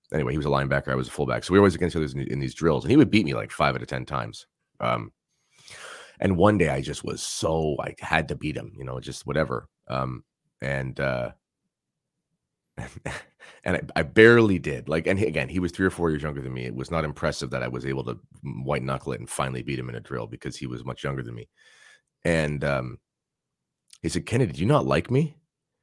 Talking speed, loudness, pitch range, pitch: 240 wpm, -25 LUFS, 65-80 Hz, 70 Hz